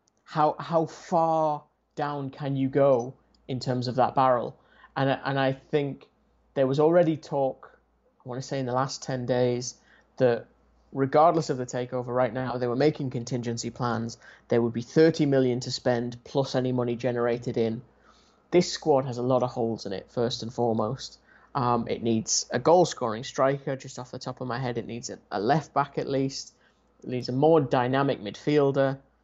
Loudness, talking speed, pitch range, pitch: -26 LUFS, 190 wpm, 120-140 Hz, 130 Hz